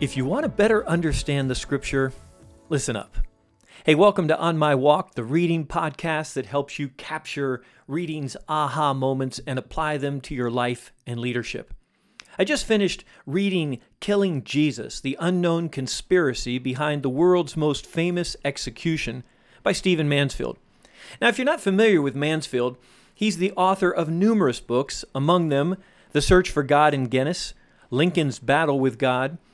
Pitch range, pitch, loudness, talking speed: 135-175 Hz, 150 Hz, -23 LUFS, 155 wpm